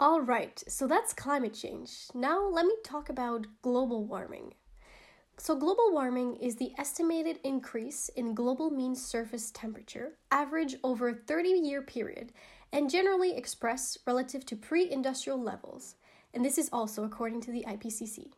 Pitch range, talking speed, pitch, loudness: 235-315 Hz, 155 wpm, 265 Hz, -32 LUFS